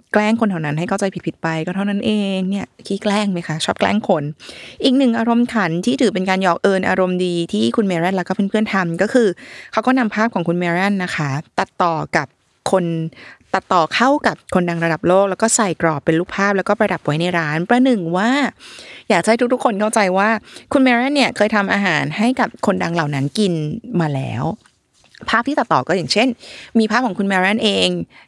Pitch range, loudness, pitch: 170-225 Hz, -17 LUFS, 195 Hz